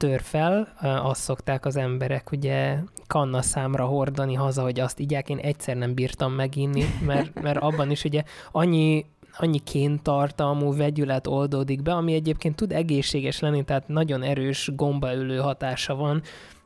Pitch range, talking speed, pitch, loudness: 135-150 Hz, 150 wpm, 140 Hz, -25 LUFS